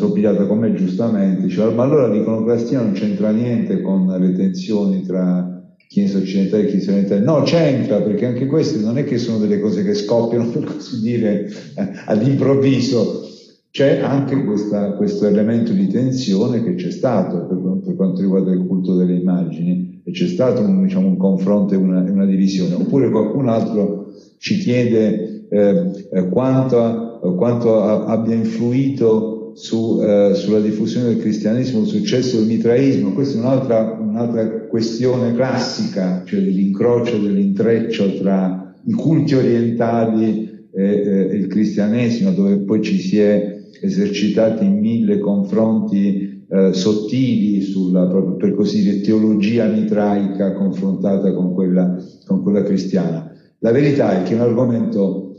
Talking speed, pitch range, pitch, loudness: 150 wpm, 95-120 Hz, 110 Hz, -17 LUFS